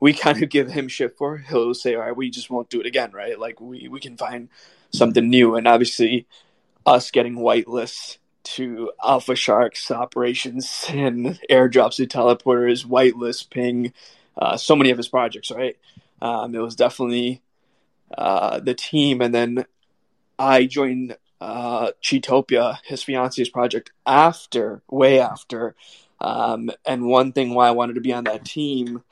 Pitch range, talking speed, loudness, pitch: 120-135 Hz, 160 wpm, -20 LUFS, 125 Hz